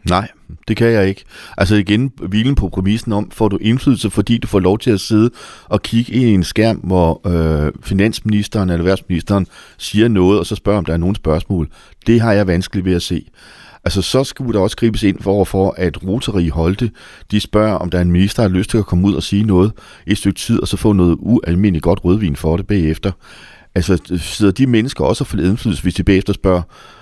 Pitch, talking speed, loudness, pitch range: 100 Hz, 230 wpm, -15 LUFS, 90-110 Hz